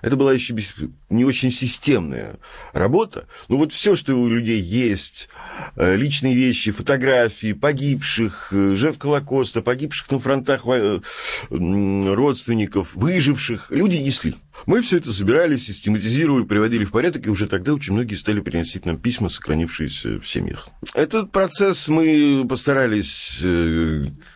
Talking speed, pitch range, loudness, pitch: 125 wpm, 100-140 Hz, -20 LUFS, 120 Hz